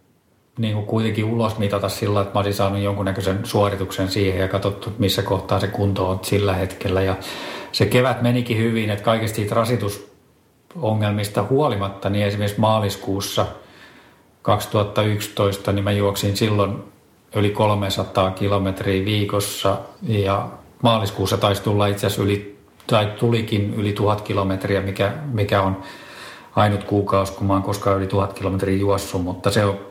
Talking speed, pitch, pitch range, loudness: 145 wpm, 100 Hz, 95-105 Hz, -21 LUFS